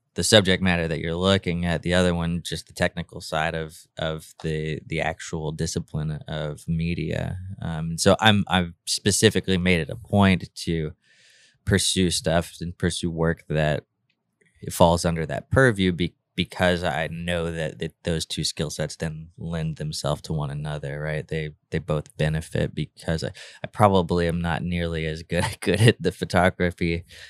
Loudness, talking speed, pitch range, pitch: -24 LUFS, 165 wpm, 80-90 Hz, 85 Hz